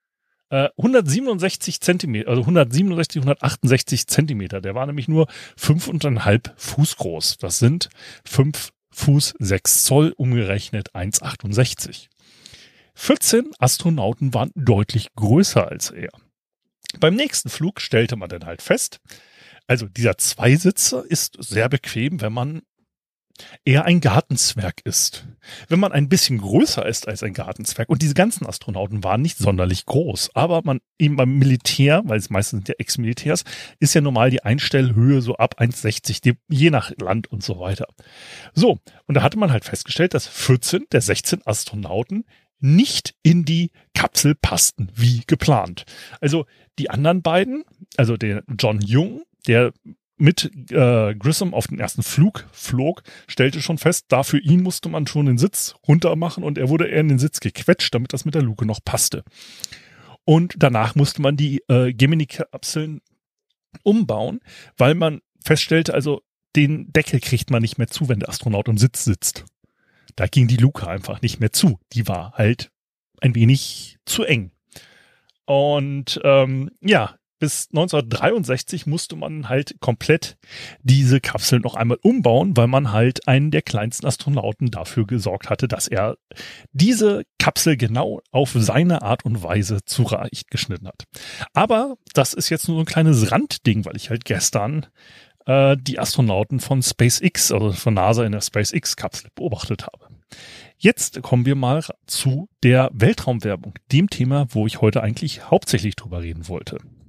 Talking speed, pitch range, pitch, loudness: 150 wpm, 115-155 Hz, 130 Hz, -19 LUFS